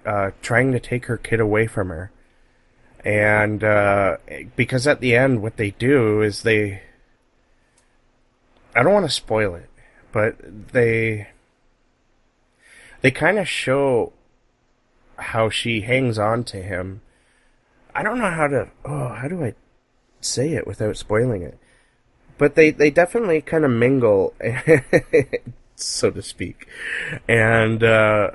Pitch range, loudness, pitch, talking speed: 105-130 Hz, -19 LUFS, 115 Hz, 135 wpm